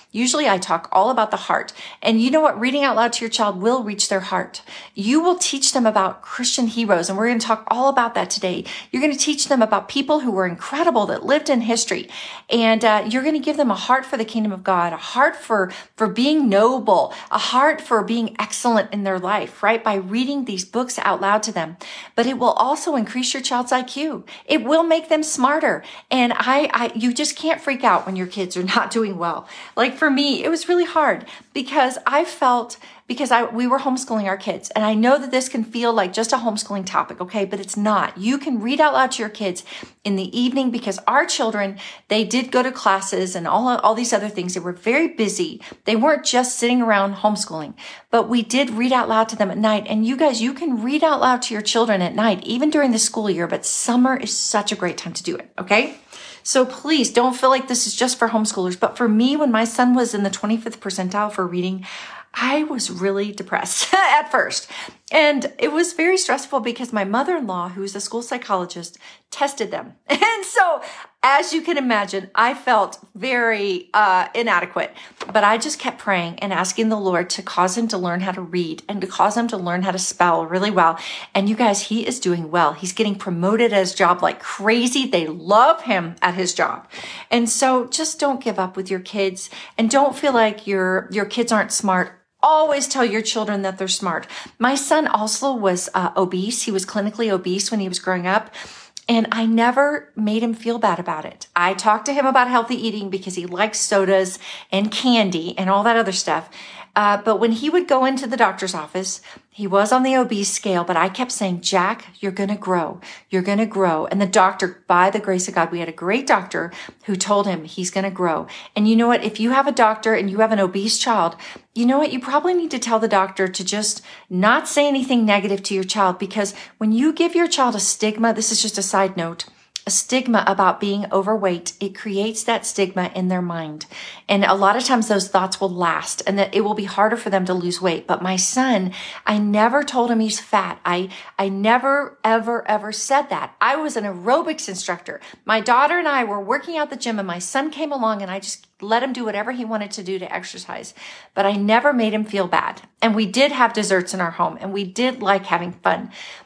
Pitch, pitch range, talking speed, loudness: 220 Hz, 195-255 Hz, 225 wpm, -19 LUFS